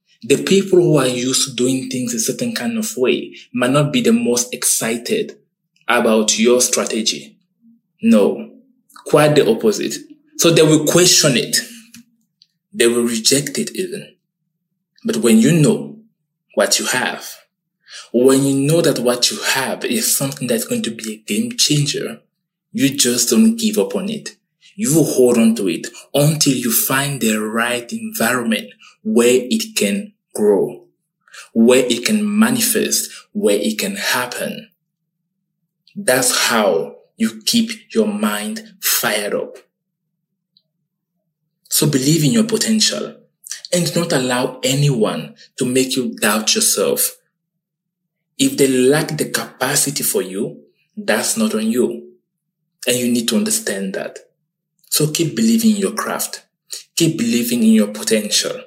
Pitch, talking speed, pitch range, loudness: 170 Hz, 140 wpm, 135-220 Hz, -16 LUFS